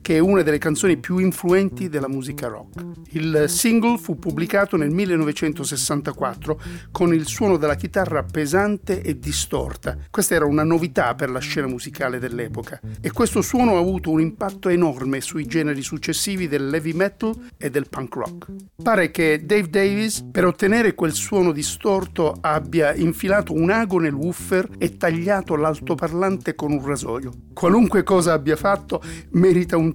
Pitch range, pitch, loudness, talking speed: 150-190 Hz, 165 Hz, -21 LUFS, 155 wpm